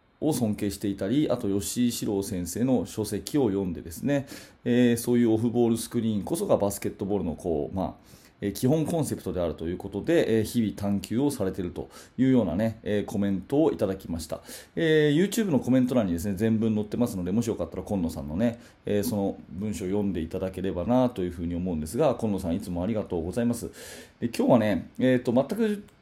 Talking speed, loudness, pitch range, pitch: 475 characters per minute, -27 LUFS, 95-120 Hz, 105 Hz